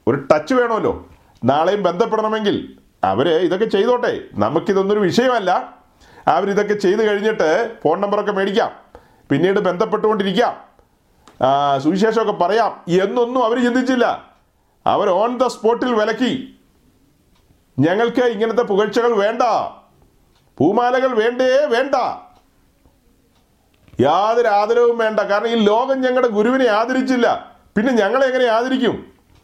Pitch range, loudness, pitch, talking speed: 205-250 Hz, -17 LUFS, 225 Hz, 95 wpm